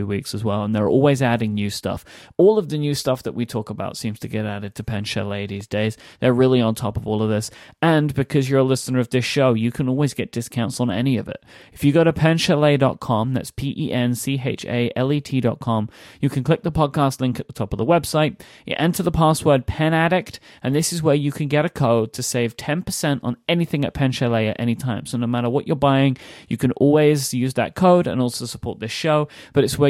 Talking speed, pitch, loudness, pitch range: 230 wpm, 130 Hz, -20 LUFS, 115-150 Hz